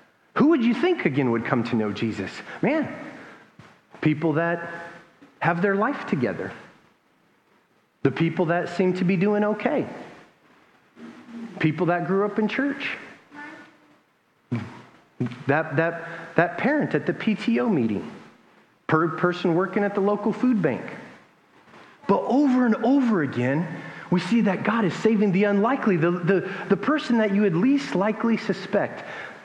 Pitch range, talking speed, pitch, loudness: 170-230 Hz, 145 wpm, 200 Hz, -23 LUFS